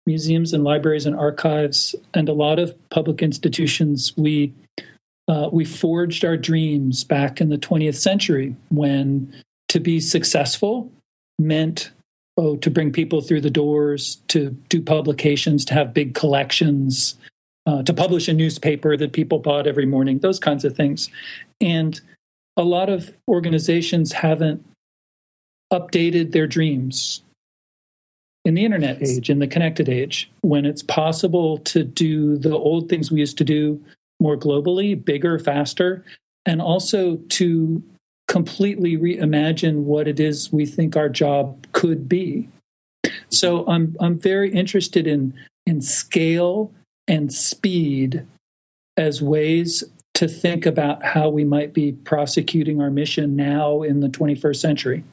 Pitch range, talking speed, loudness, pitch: 145-170 Hz, 140 wpm, -20 LUFS, 155 Hz